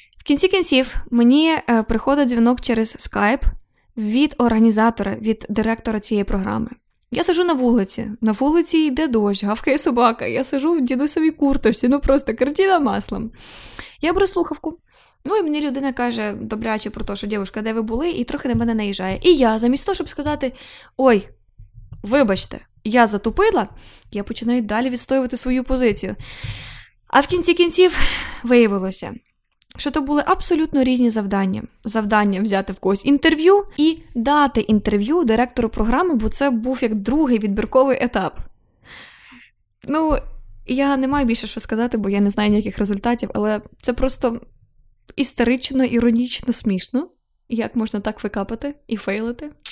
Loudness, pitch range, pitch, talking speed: -19 LUFS, 215-285 Hz, 240 Hz, 150 wpm